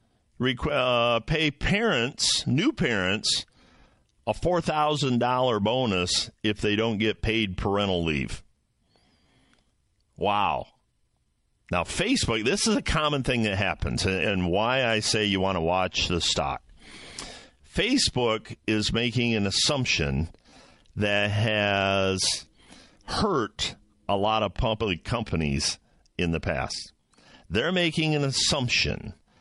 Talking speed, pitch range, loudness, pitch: 115 wpm, 95-125 Hz, -25 LUFS, 105 Hz